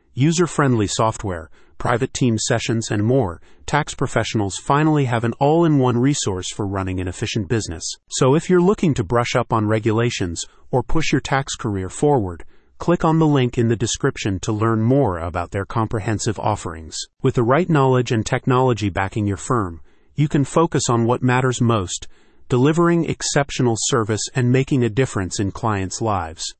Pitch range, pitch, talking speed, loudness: 105-135 Hz, 120 Hz, 175 wpm, -20 LUFS